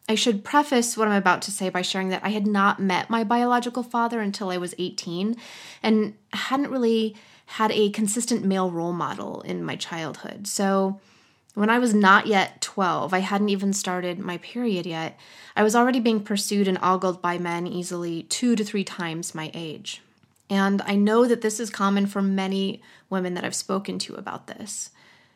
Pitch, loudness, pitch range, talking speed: 200 Hz, -24 LUFS, 185-220 Hz, 190 wpm